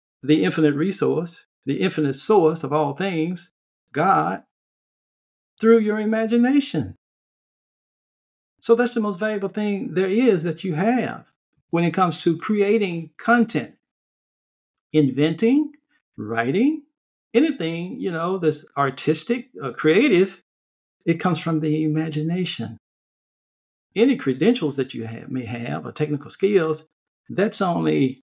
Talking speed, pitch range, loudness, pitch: 120 wpm, 150-215 Hz, -21 LUFS, 170 Hz